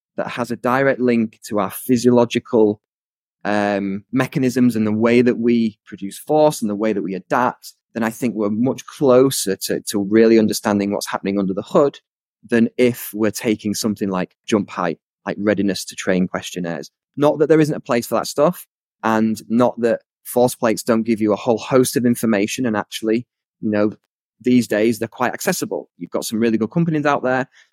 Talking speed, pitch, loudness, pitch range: 195 wpm, 115 Hz, -19 LUFS, 105-125 Hz